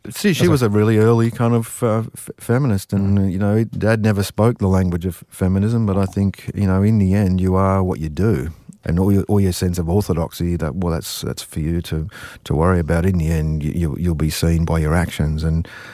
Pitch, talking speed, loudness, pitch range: 95 Hz, 235 wpm, -18 LUFS, 85-110 Hz